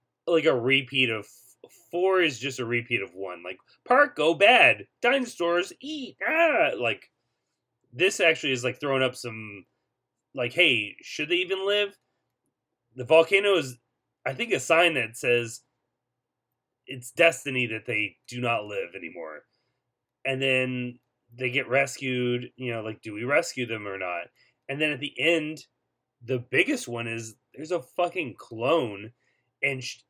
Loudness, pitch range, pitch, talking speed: -25 LUFS, 120-165 Hz, 130 Hz, 155 wpm